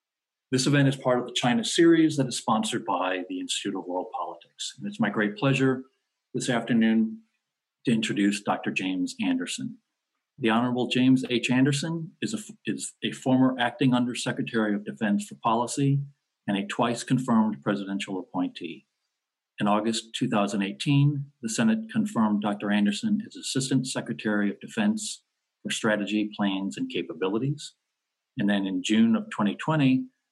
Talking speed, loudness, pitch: 145 wpm, -26 LUFS, 130 Hz